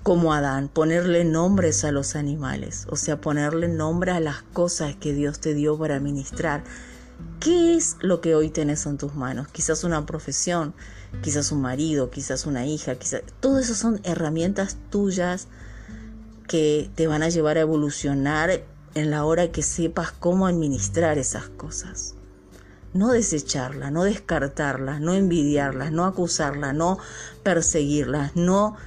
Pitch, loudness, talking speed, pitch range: 150 Hz, -23 LUFS, 150 wpm, 140-170 Hz